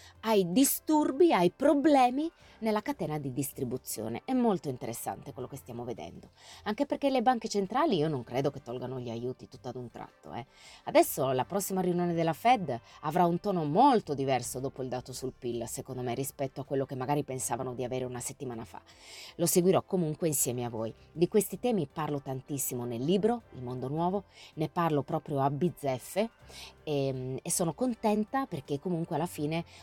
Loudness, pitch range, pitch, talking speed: -31 LUFS, 130-195 Hz, 150 Hz, 180 wpm